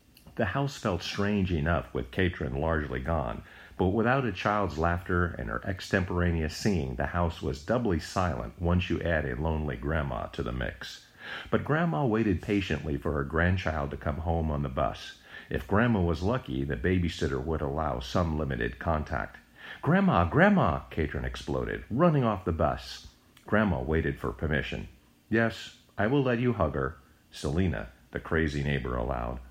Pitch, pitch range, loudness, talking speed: 80 Hz, 70-95 Hz, -29 LUFS, 165 wpm